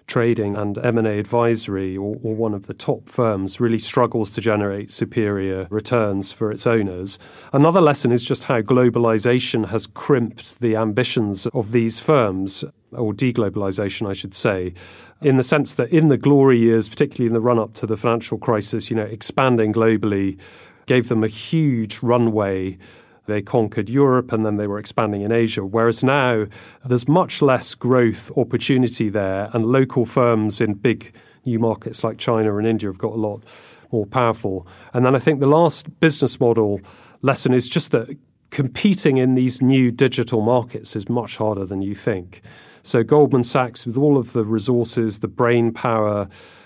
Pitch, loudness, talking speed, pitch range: 115 Hz, -19 LUFS, 170 wpm, 105-125 Hz